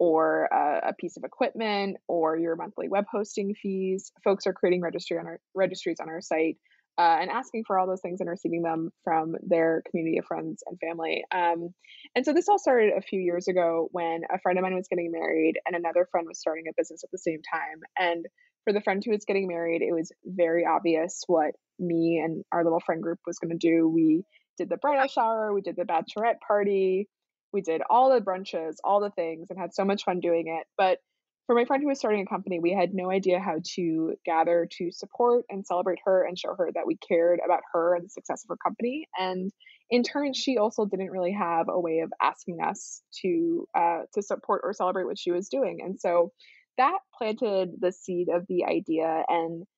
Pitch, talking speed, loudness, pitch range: 185 Hz, 220 wpm, -27 LUFS, 170-210 Hz